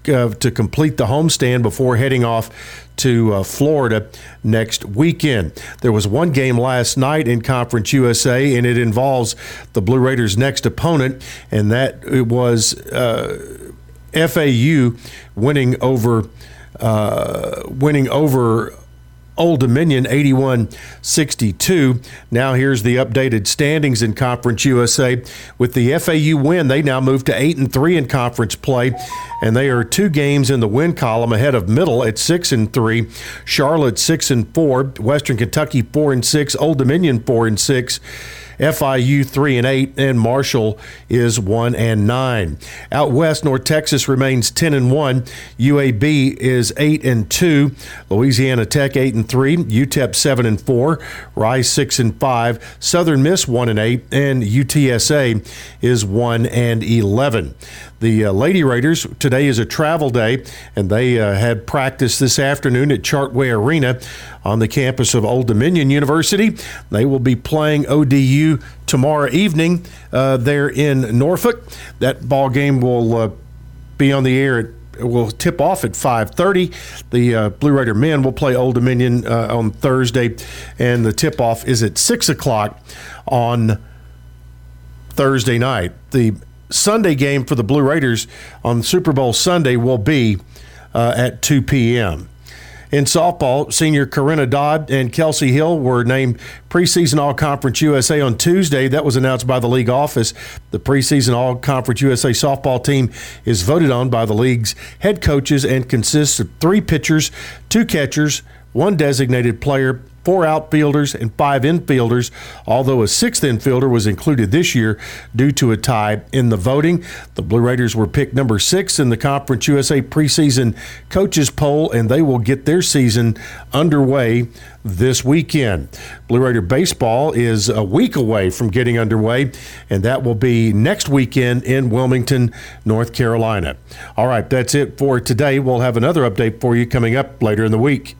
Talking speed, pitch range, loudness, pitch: 155 wpm, 115-140 Hz, -15 LUFS, 130 Hz